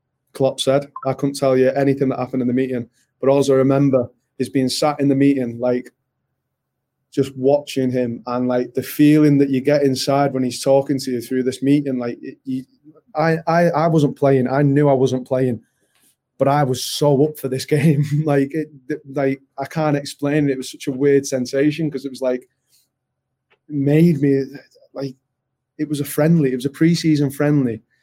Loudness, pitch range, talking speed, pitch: -18 LUFS, 130-145 Hz, 195 wpm, 140 Hz